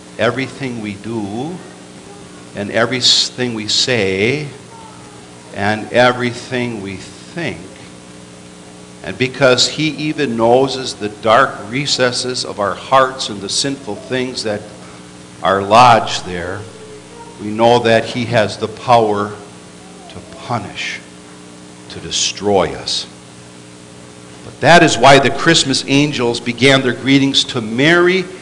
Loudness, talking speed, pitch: -14 LUFS, 115 wpm, 110 Hz